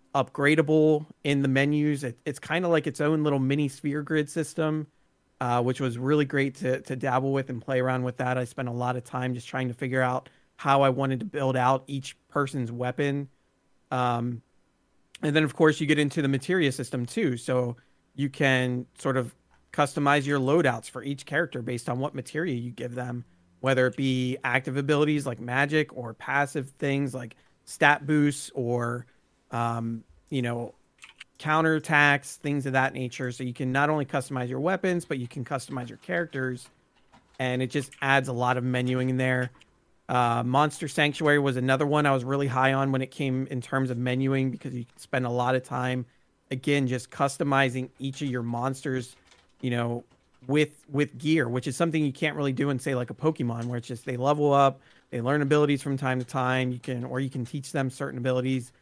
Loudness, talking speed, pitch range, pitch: -27 LUFS, 200 wpm, 125-145 Hz, 130 Hz